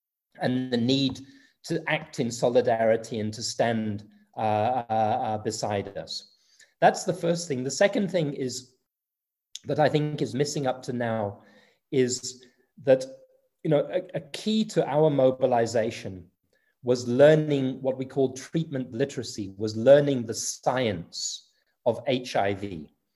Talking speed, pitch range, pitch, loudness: 135 wpm, 110-140 Hz, 130 Hz, -26 LUFS